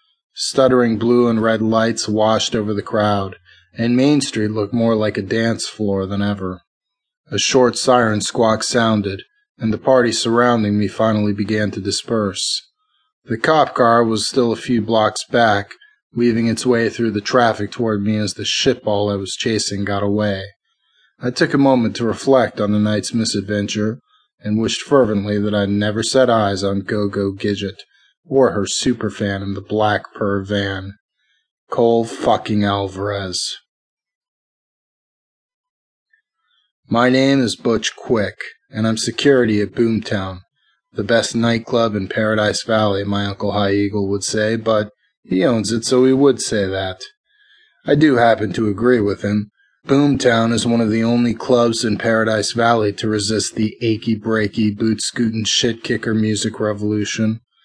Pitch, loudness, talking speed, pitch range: 110 Hz, -17 LUFS, 160 wpm, 105-120 Hz